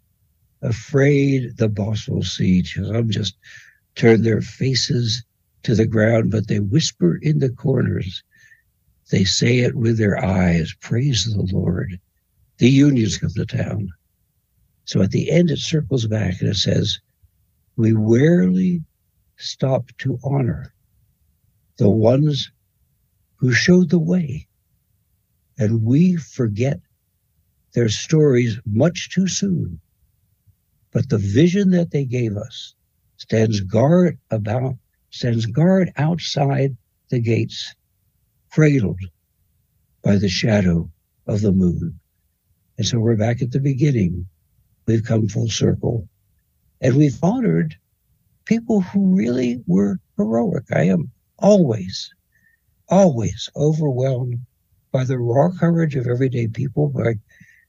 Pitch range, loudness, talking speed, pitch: 100-140 Hz, -19 LUFS, 120 wpm, 115 Hz